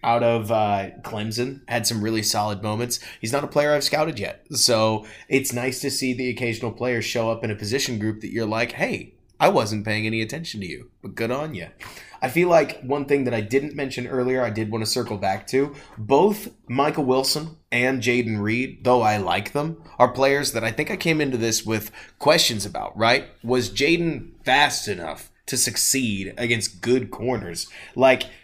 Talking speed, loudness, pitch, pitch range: 200 wpm, -22 LUFS, 120 Hz, 110-135 Hz